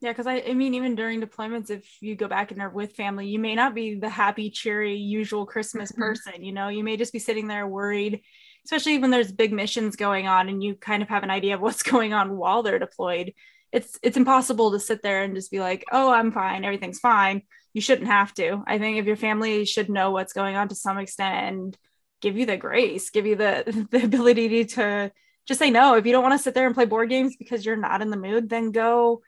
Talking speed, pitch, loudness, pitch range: 250 wpm, 215 Hz, -23 LUFS, 200-240 Hz